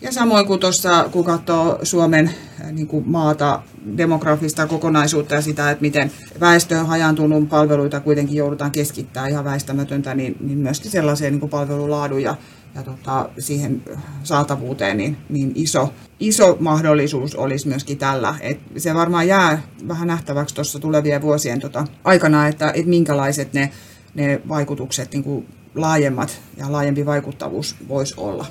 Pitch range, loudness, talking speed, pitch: 140-155 Hz, -18 LUFS, 145 wpm, 145 Hz